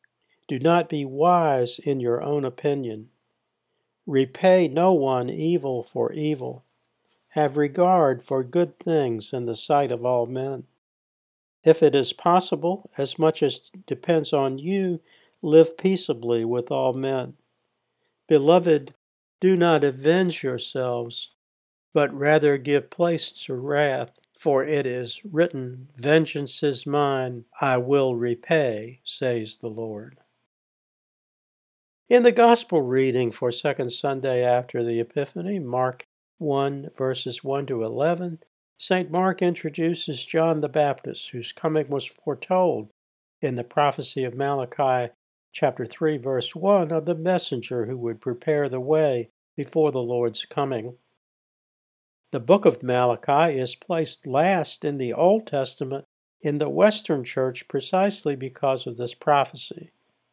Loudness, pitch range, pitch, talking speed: -23 LUFS, 125-160 Hz, 140 Hz, 130 wpm